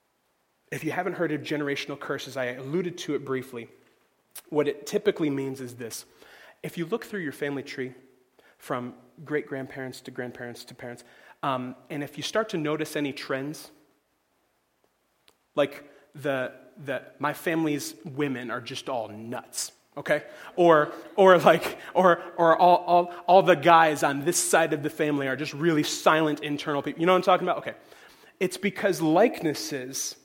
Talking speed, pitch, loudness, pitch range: 165 wpm, 150 Hz, -25 LUFS, 135-170 Hz